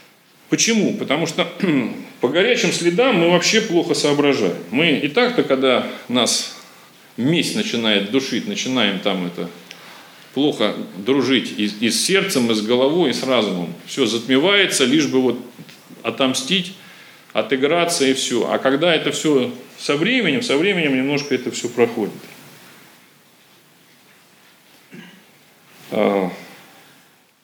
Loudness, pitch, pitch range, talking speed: -18 LUFS, 140 Hz, 125-175 Hz, 115 wpm